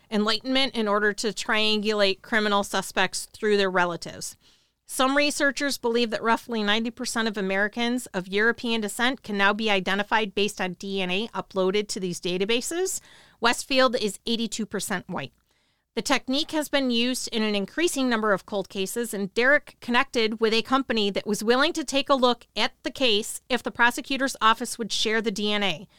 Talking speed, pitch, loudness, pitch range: 165 wpm, 225 Hz, -24 LUFS, 200-250 Hz